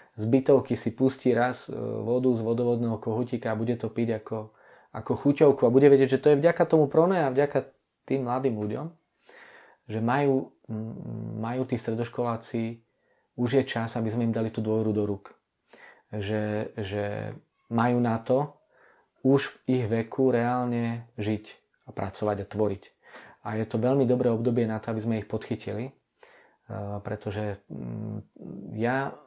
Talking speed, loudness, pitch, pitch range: 155 wpm, -27 LUFS, 115 Hz, 110-130 Hz